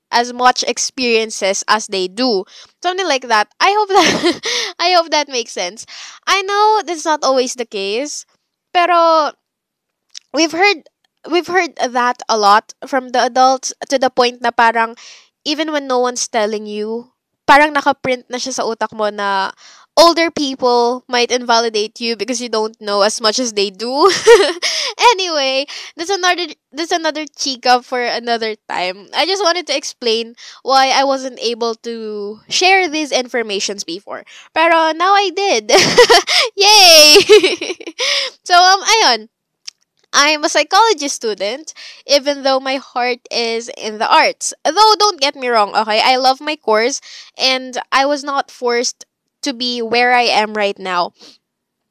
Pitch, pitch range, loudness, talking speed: 260 Hz, 230-330 Hz, -14 LUFS, 155 wpm